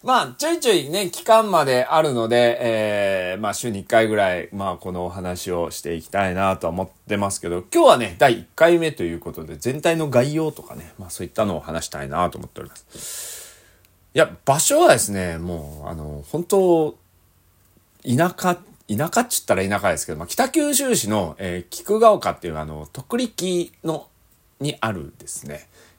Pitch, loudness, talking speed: 105 Hz, -20 LUFS, 345 characters per minute